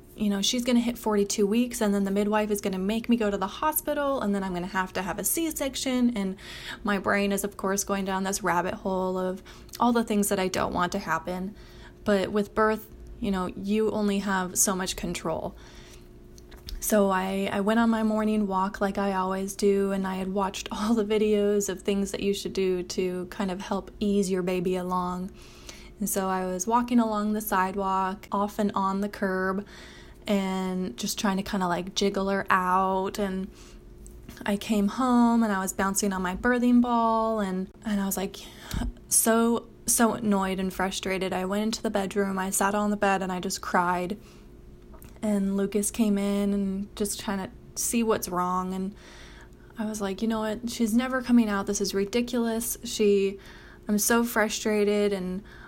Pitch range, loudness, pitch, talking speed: 190-215 Hz, -27 LUFS, 200 Hz, 200 wpm